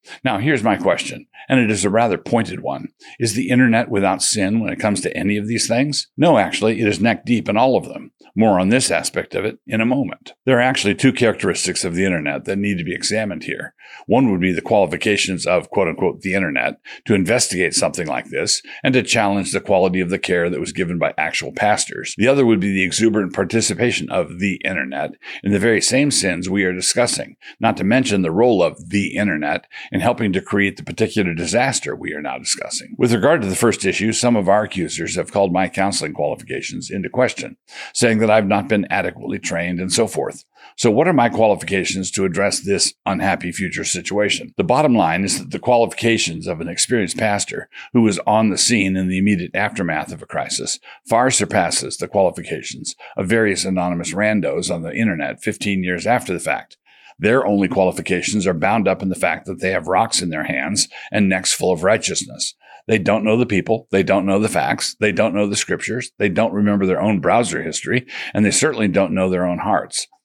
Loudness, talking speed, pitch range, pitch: -18 LUFS, 215 wpm, 95-115 Hz, 100 Hz